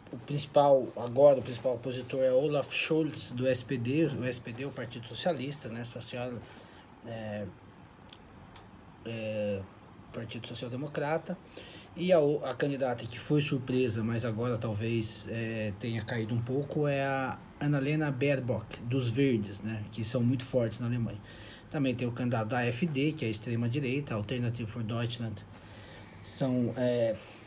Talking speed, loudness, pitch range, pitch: 145 wpm, -31 LUFS, 110-135 Hz, 120 Hz